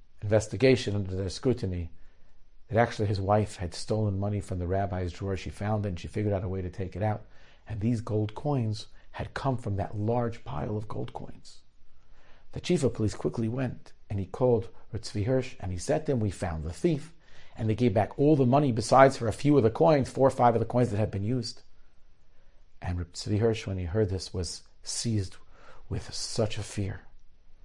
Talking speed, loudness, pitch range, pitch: 215 wpm, -29 LUFS, 95-120 Hz, 105 Hz